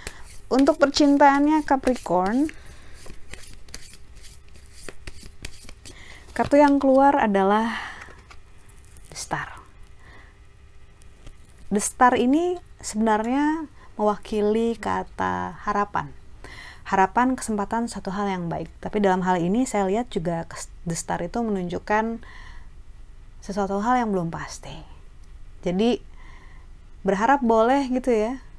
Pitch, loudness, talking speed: 210 Hz, -23 LUFS, 90 wpm